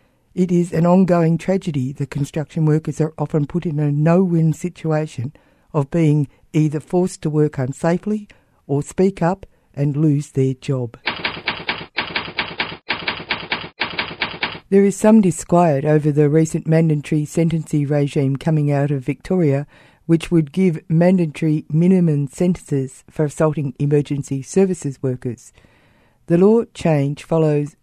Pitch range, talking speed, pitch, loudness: 145-170 Hz, 125 wpm, 155 Hz, -19 LUFS